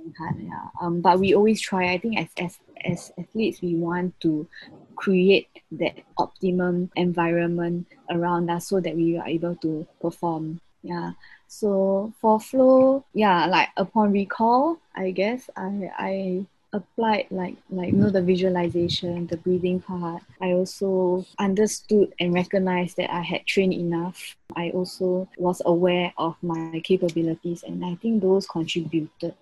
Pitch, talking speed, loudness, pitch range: 180 Hz, 145 wpm, -24 LUFS, 170-195 Hz